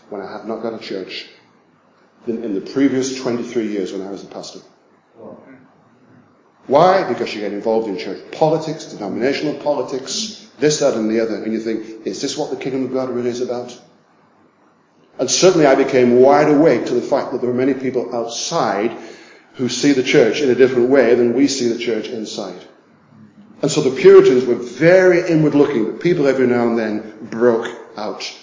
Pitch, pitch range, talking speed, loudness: 125 Hz, 115-145 Hz, 190 wpm, -16 LUFS